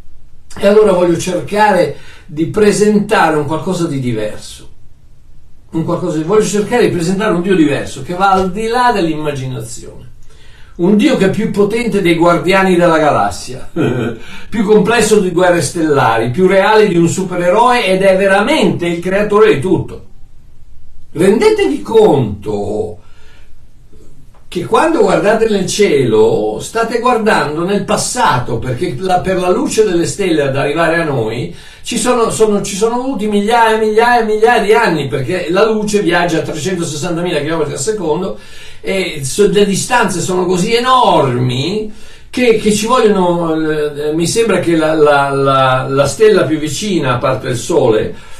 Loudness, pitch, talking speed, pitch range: -12 LUFS, 185 Hz, 145 wpm, 155-215 Hz